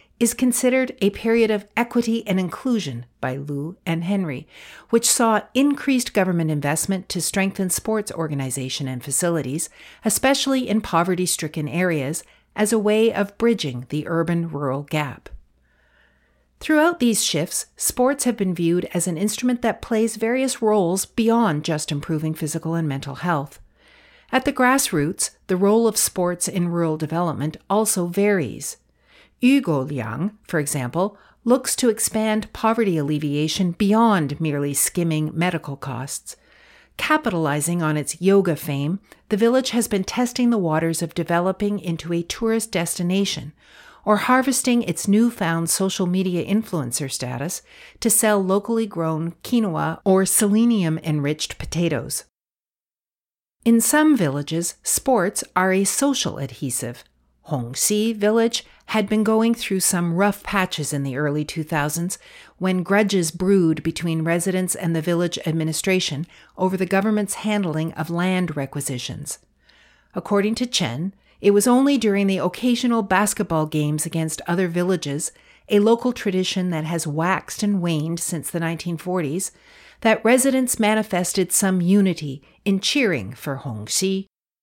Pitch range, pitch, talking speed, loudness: 155-220 Hz, 185 Hz, 135 wpm, -21 LUFS